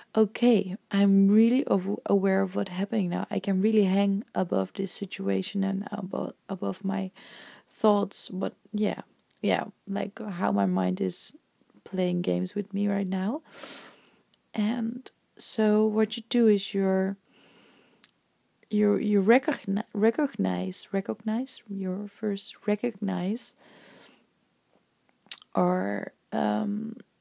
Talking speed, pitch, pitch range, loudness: 110 wpm, 200 Hz, 190-215 Hz, -27 LUFS